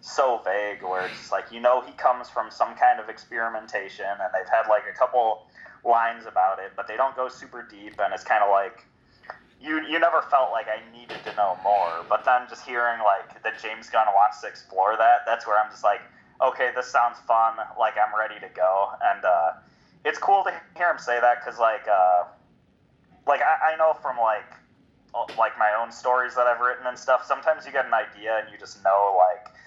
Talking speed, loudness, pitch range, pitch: 220 wpm, -24 LUFS, 105-125 Hz, 115 Hz